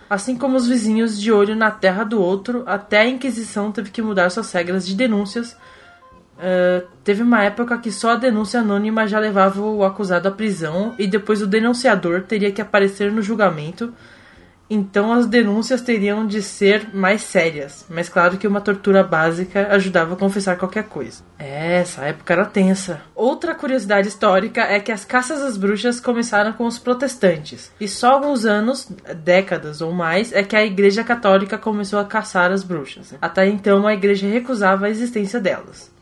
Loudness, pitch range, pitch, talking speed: -18 LUFS, 190-225 Hz, 205 Hz, 175 wpm